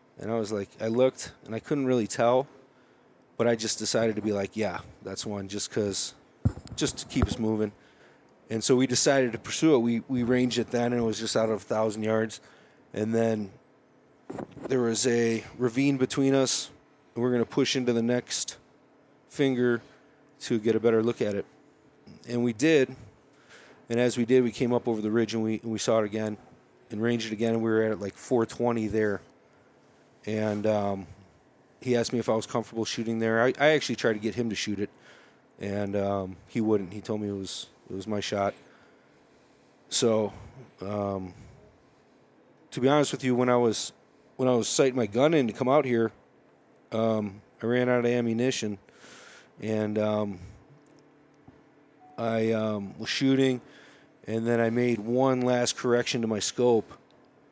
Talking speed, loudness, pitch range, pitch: 190 wpm, -27 LUFS, 105-125 Hz, 115 Hz